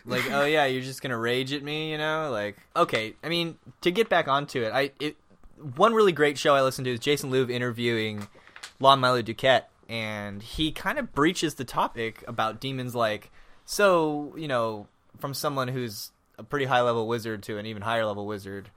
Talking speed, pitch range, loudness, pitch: 205 wpm, 110-145 Hz, -26 LUFS, 130 Hz